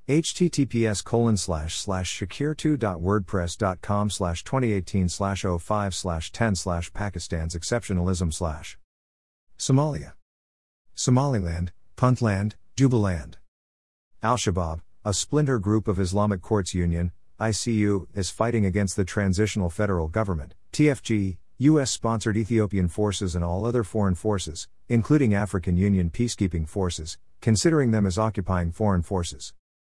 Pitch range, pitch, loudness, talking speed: 85-110 Hz, 100 Hz, -25 LUFS, 115 wpm